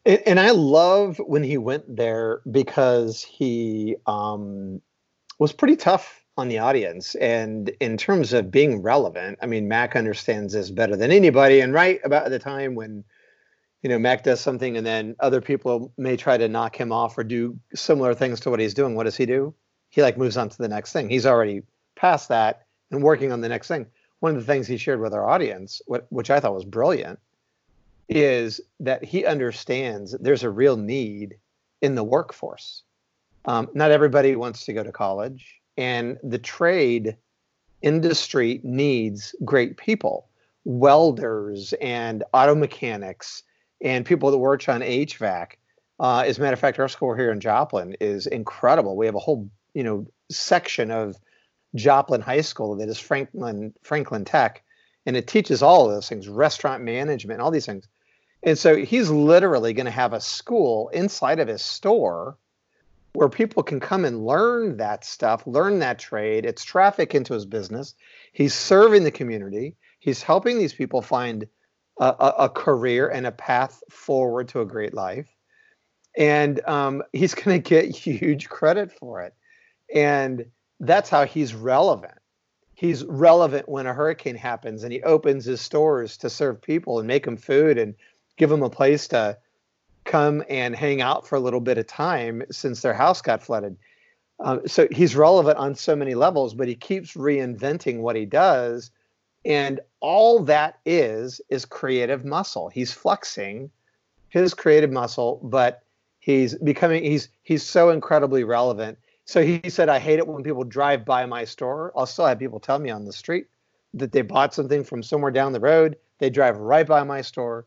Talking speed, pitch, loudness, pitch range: 175 wpm, 135 Hz, -21 LUFS, 120-150 Hz